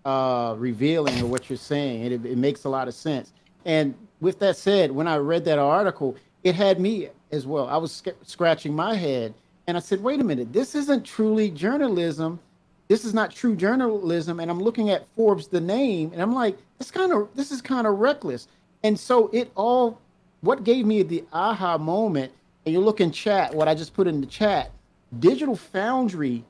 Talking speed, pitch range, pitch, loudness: 205 wpm, 150-220 Hz, 185 Hz, -24 LUFS